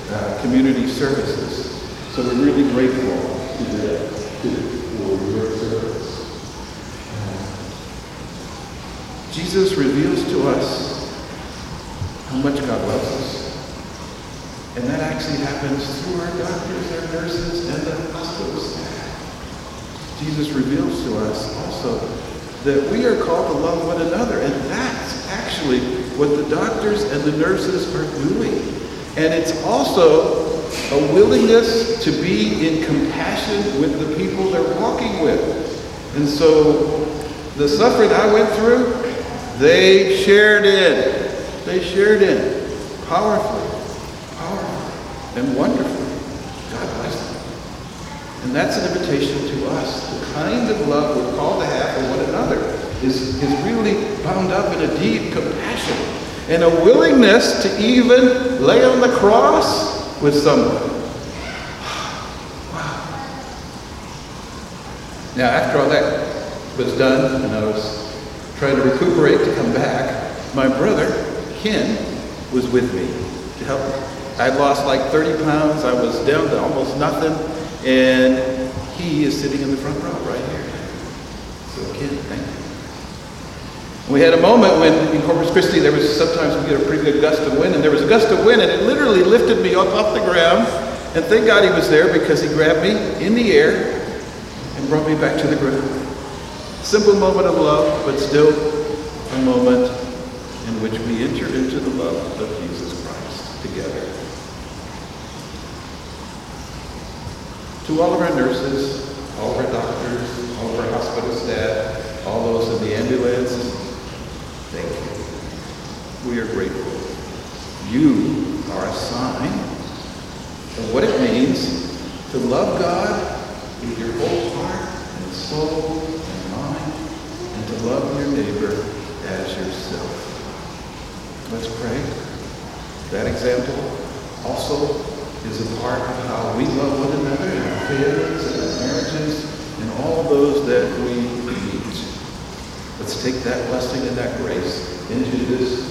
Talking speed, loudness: 140 wpm, -18 LUFS